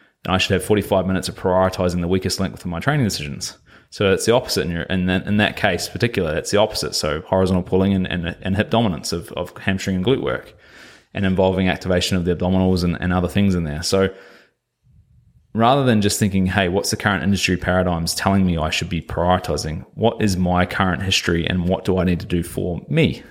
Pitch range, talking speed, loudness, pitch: 90-95 Hz, 225 wpm, -20 LUFS, 95 Hz